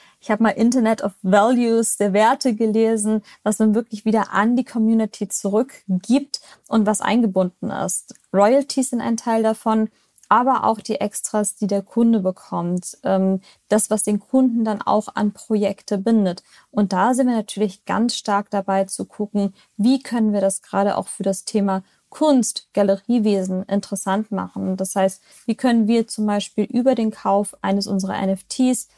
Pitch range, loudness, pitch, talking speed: 200-225 Hz, -20 LUFS, 210 Hz, 165 wpm